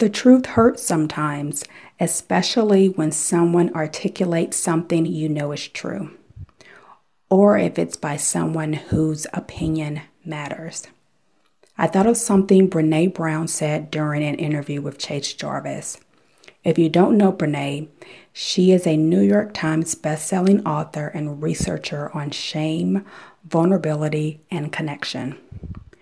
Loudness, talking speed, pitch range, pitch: -20 LUFS, 125 wpm, 150-185 Hz, 160 Hz